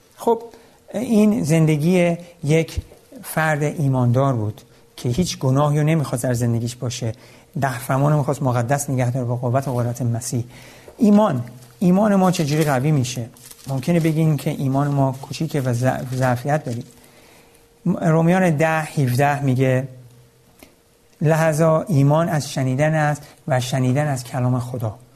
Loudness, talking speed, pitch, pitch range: -20 LUFS, 135 wpm, 140 Hz, 125-160 Hz